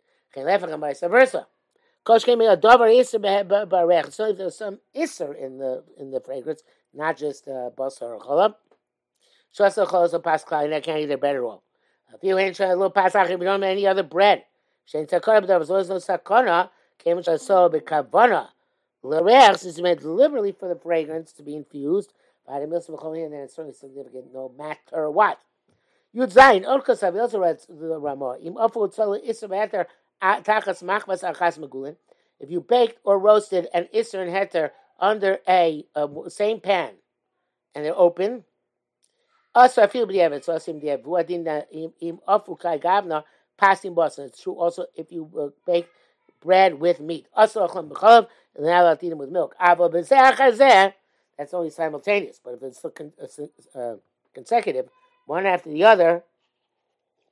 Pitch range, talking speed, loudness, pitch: 160-215 Hz, 130 wpm, -20 LUFS, 180 Hz